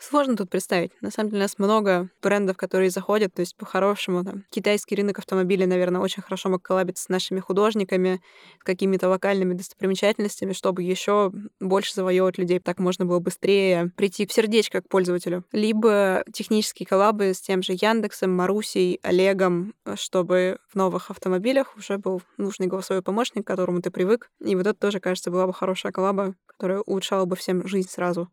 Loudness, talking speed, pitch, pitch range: -24 LUFS, 175 wpm, 190 Hz, 185-205 Hz